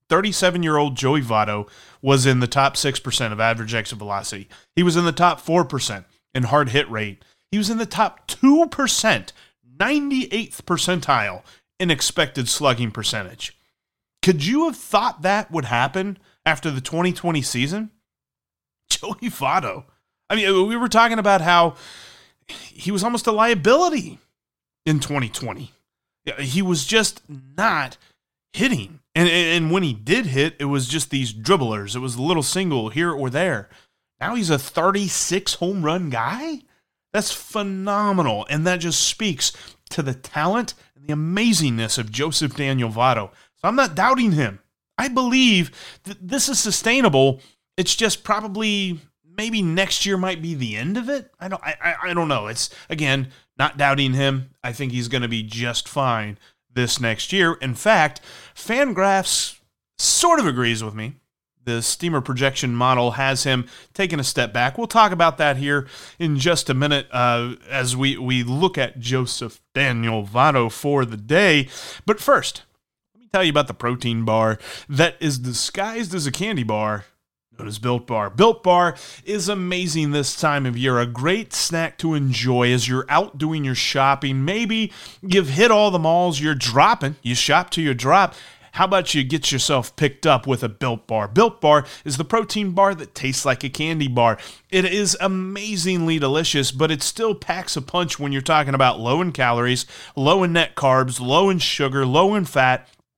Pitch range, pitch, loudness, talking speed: 130-190 Hz, 150 Hz, -20 LUFS, 175 wpm